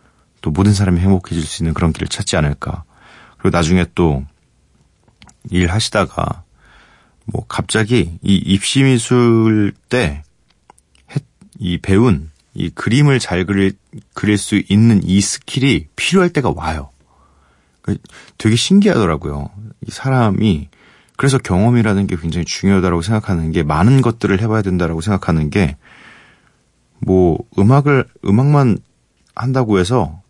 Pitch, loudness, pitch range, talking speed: 100 Hz, -15 LUFS, 85-115 Hz, 265 characters per minute